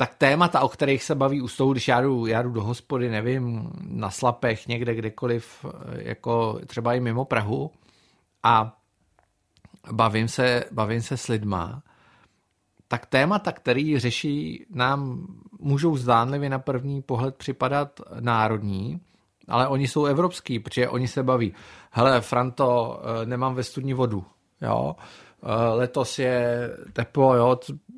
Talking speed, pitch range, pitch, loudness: 135 wpm, 115-135 Hz, 125 Hz, -24 LUFS